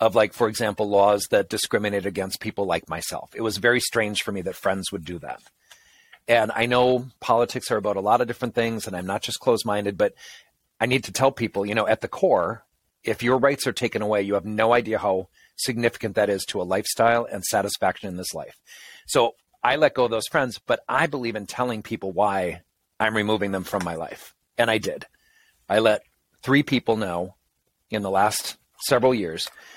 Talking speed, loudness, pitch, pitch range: 210 wpm, -23 LUFS, 110 Hz, 100-120 Hz